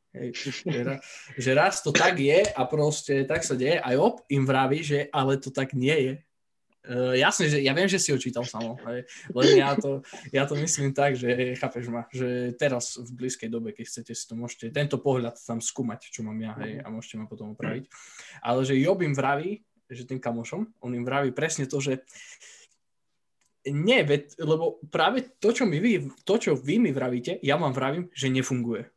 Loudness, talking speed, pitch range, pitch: -26 LUFS, 195 wpm, 125-150 Hz, 135 Hz